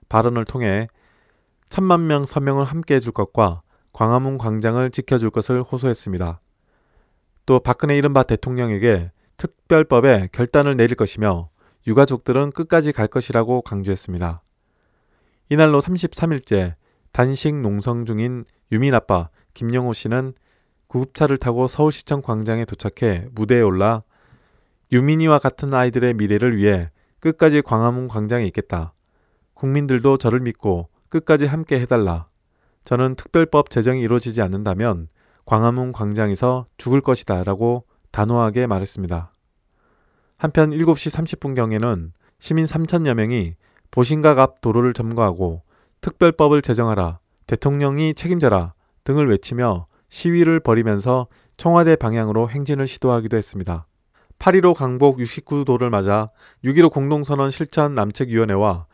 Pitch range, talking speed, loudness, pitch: 105-140 Hz, 295 characters per minute, -19 LUFS, 120 Hz